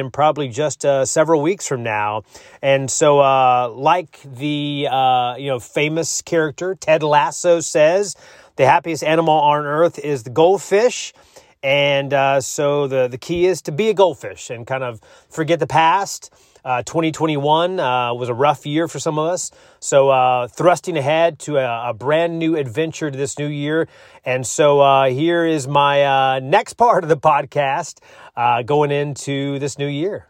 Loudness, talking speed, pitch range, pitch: -17 LUFS, 175 wpm, 135-160 Hz, 145 Hz